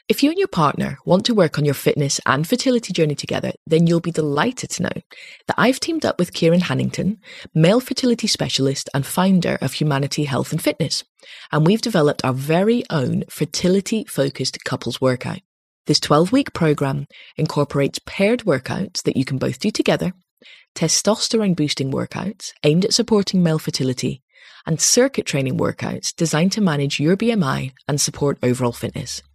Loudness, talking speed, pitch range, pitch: -19 LUFS, 170 wpm, 140-200 Hz, 160 Hz